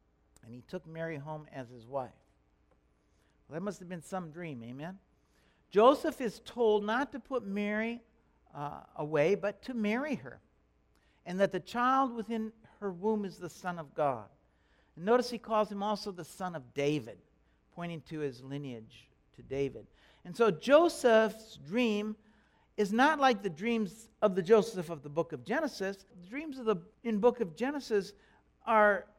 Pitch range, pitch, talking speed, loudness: 150-225 Hz, 195 Hz, 175 wpm, -32 LUFS